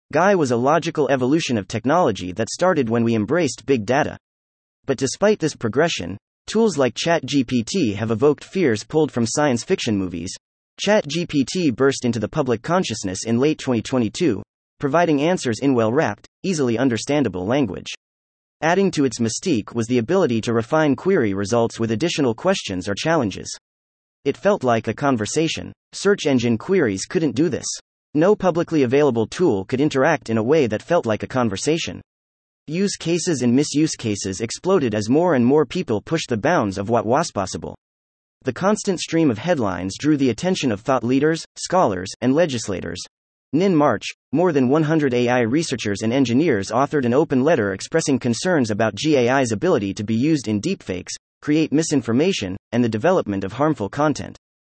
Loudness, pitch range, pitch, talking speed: -20 LUFS, 110-155 Hz, 130 Hz, 165 wpm